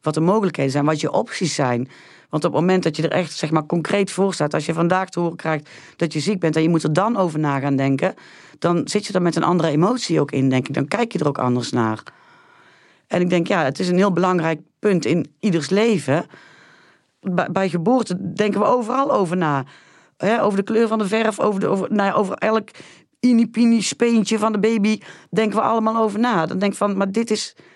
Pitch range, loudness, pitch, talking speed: 160-215 Hz, -20 LUFS, 185 Hz, 240 wpm